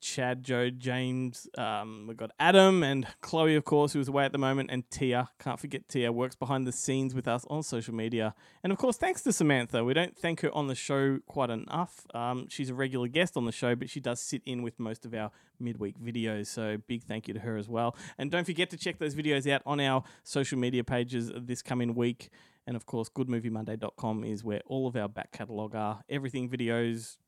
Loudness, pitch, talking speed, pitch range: -31 LUFS, 125 Hz, 225 wpm, 115-140 Hz